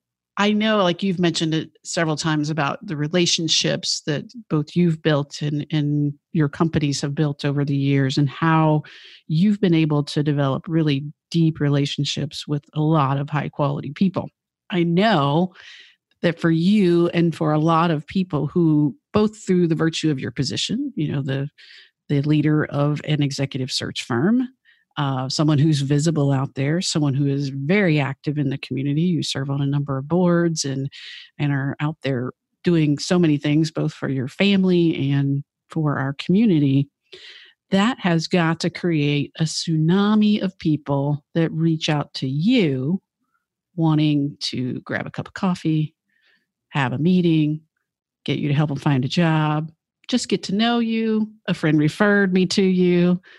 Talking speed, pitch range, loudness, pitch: 170 wpm, 145-180 Hz, -21 LUFS, 155 Hz